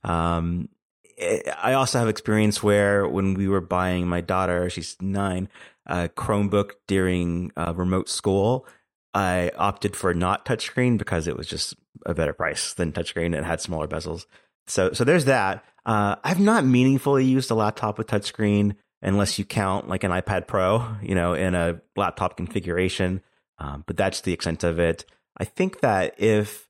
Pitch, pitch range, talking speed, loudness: 95 Hz, 85-105 Hz, 170 wpm, -24 LUFS